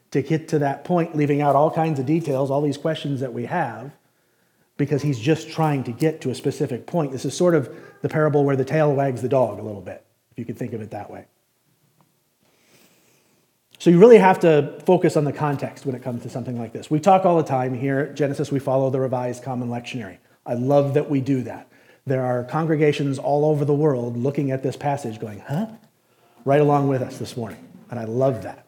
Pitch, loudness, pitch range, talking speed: 140 Hz, -21 LUFS, 125-155 Hz, 230 wpm